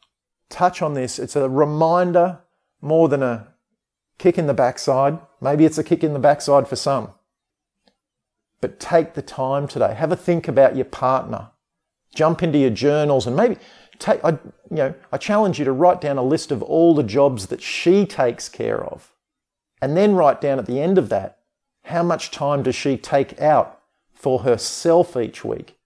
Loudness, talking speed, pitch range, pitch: -19 LUFS, 185 wpm, 140-175 Hz, 150 Hz